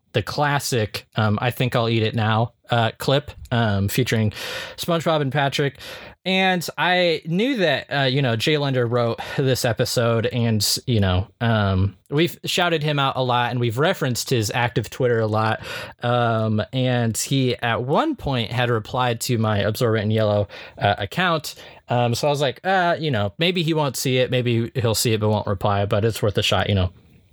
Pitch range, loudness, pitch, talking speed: 110-140 Hz, -21 LUFS, 120 Hz, 195 wpm